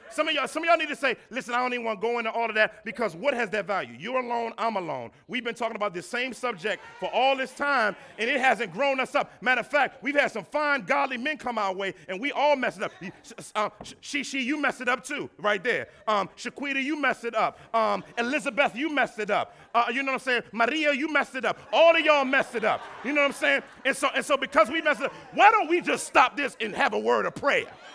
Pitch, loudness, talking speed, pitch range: 255 Hz, -26 LUFS, 275 wpm, 225-285 Hz